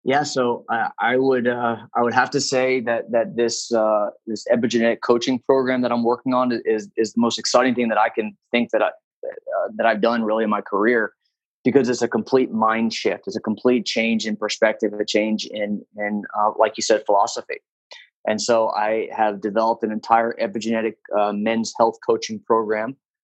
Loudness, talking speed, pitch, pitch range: -21 LUFS, 200 wpm, 115 Hz, 110-125 Hz